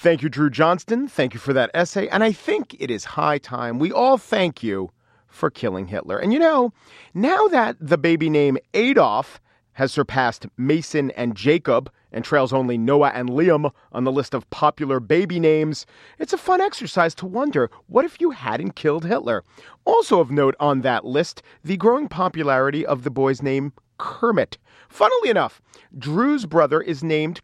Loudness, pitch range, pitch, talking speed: -20 LUFS, 135-190 Hz, 155 Hz, 180 wpm